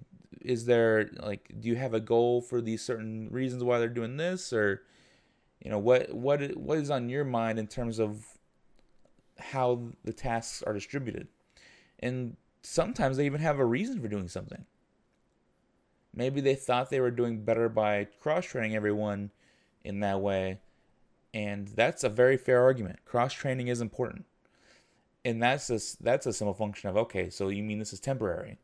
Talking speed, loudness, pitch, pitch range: 170 wpm, -30 LUFS, 115 Hz, 105-125 Hz